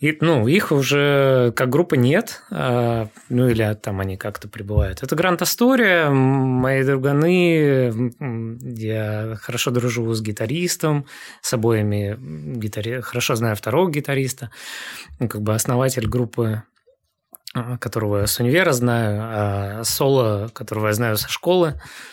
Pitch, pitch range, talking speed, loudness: 125 Hz, 110-140 Hz, 125 wpm, -20 LUFS